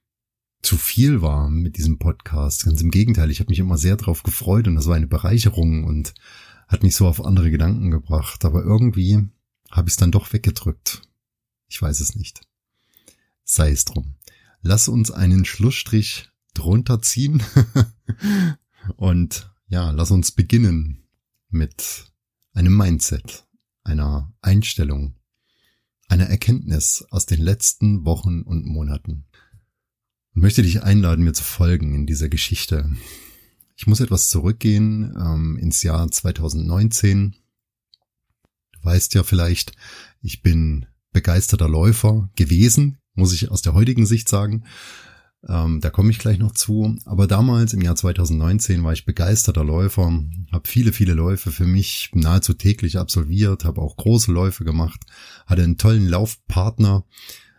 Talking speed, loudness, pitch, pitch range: 140 wpm, -19 LUFS, 95 Hz, 85-110 Hz